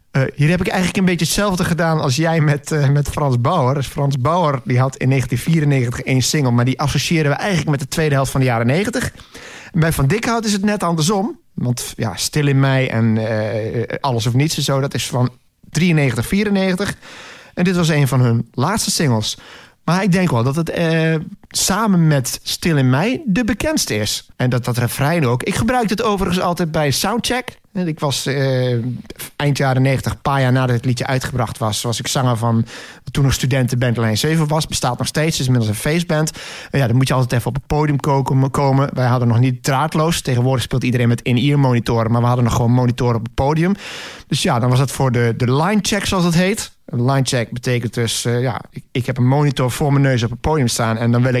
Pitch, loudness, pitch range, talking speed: 135 Hz, -17 LUFS, 125-160 Hz, 230 wpm